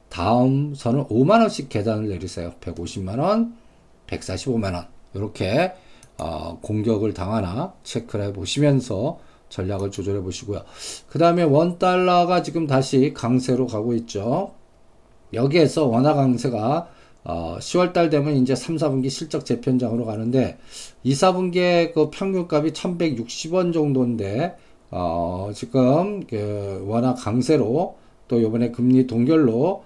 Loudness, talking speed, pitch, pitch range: -21 LUFS, 245 characters per minute, 125 Hz, 105-155 Hz